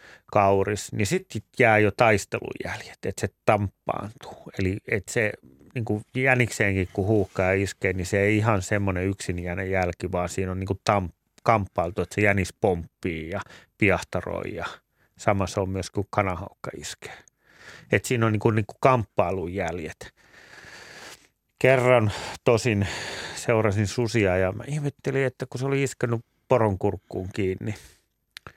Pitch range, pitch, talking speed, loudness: 95-115 Hz, 105 Hz, 140 wpm, -25 LUFS